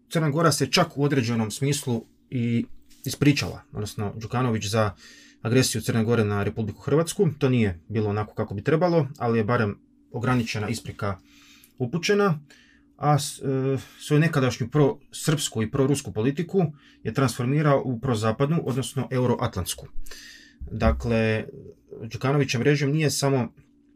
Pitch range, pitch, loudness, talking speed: 115-145 Hz, 130 Hz, -25 LUFS, 125 wpm